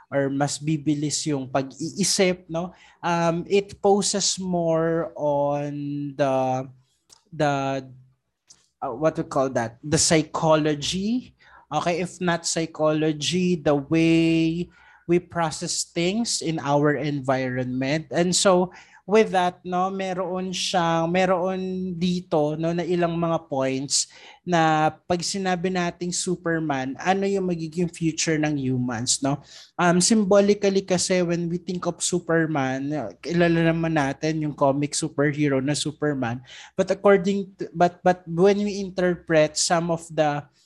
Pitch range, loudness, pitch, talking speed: 145-180 Hz, -23 LUFS, 165 Hz, 125 wpm